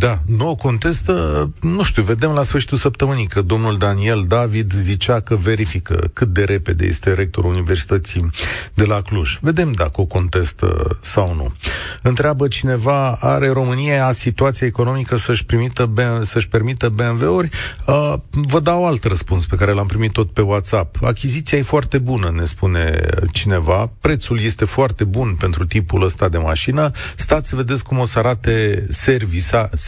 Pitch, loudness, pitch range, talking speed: 110 Hz, -17 LUFS, 95-130 Hz, 160 wpm